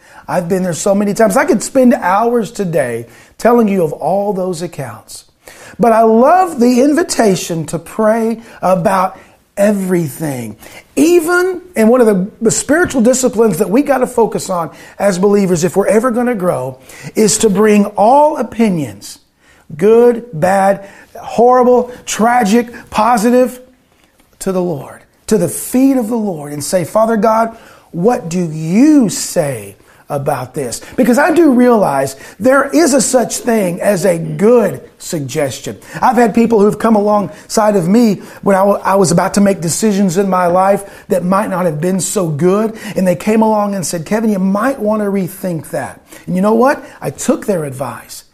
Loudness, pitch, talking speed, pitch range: -13 LUFS, 205 Hz, 170 wpm, 180-240 Hz